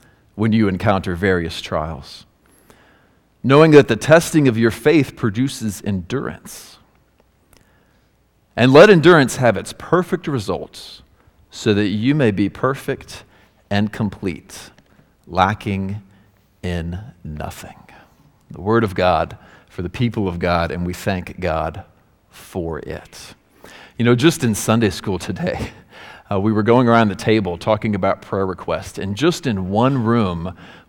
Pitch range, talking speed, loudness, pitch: 95-120 Hz, 135 wpm, -17 LUFS, 105 Hz